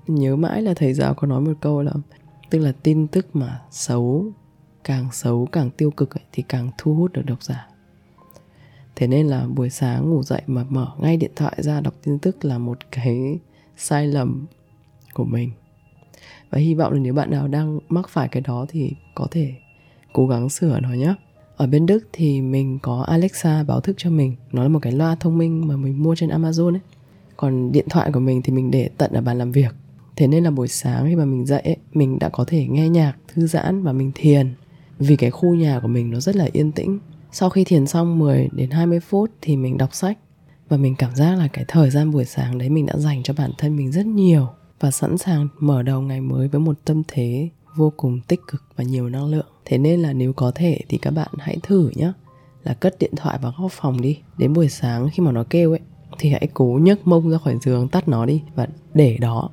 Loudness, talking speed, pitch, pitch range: -20 LUFS, 235 wpm, 145 Hz, 130-160 Hz